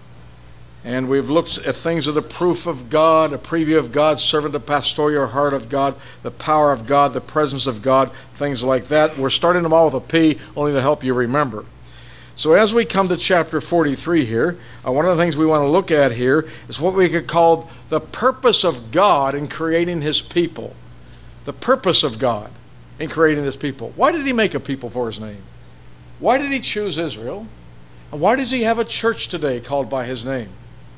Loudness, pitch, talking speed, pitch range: -18 LUFS, 145 Hz, 215 wpm, 125-165 Hz